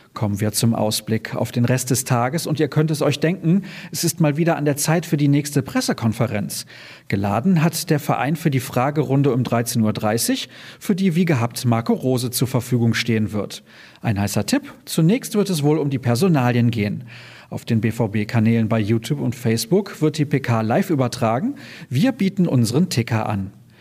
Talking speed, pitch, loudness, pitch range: 185 wpm, 130 Hz, -20 LUFS, 115-160 Hz